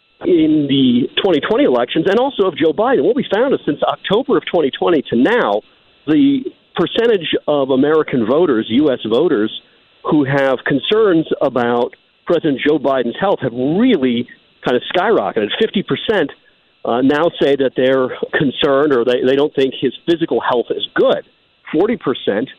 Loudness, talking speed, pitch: -15 LUFS, 150 wpm, 155 Hz